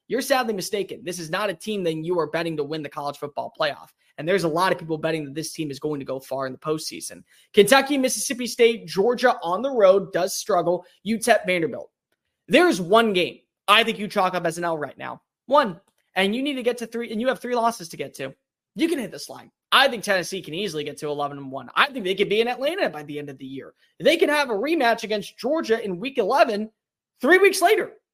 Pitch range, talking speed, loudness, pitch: 160-235 Hz, 250 wpm, -22 LUFS, 195 Hz